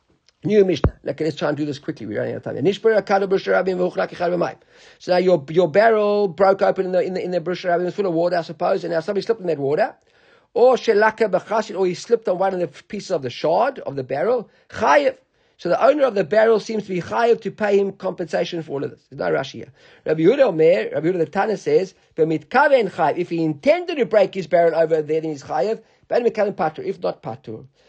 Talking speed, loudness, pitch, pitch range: 220 wpm, -20 LUFS, 195 Hz, 170-220 Hz